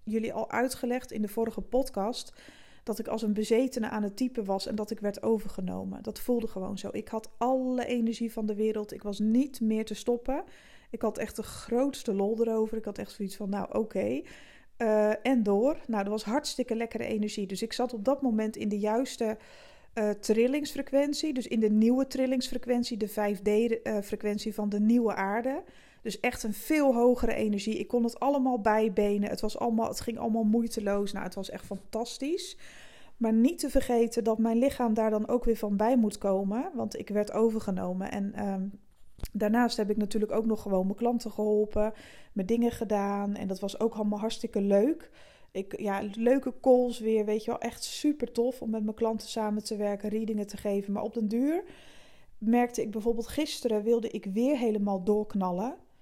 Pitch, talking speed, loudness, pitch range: 220 Hz, 195 wpm, -30 LUFS, 210-240 Hz